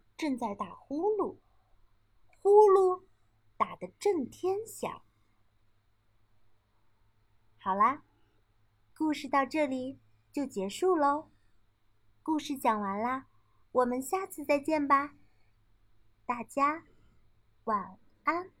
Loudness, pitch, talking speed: -30 LUFS, 245 Hz, 125 characters per minute